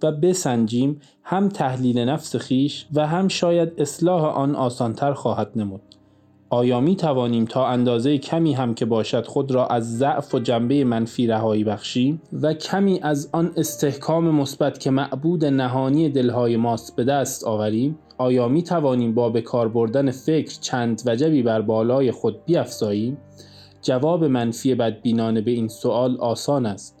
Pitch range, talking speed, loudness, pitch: 115-150 Hz, 150 wpm, -21 LUFS, 130 Hz